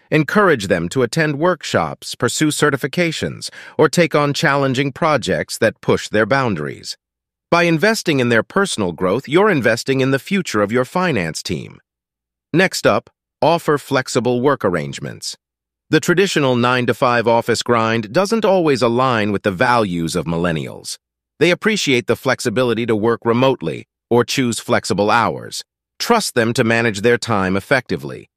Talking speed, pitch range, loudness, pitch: 150 wpm, 110-155 Hz, -17 LUFS, 125 Hz